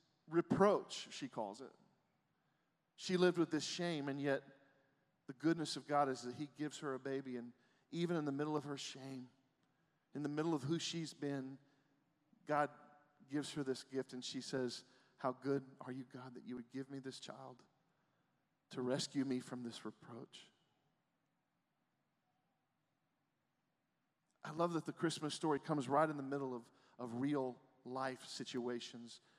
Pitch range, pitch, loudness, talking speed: 130-155 Hz, 140 Hz, -42 LUFS, 160 wpm